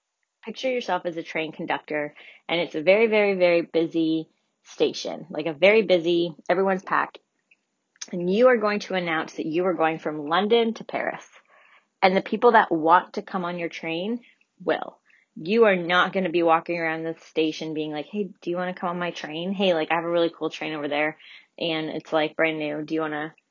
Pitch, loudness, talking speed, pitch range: 170 Hz, -24 LUFS, 215 wpm, 160-190 Hz